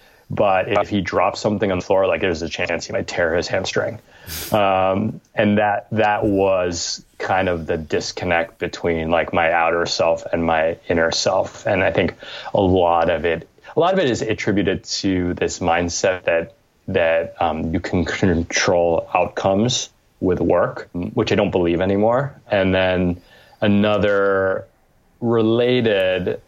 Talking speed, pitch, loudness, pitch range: 155 wpm, 95 Hz, -19 LUFS, 85-105 Hz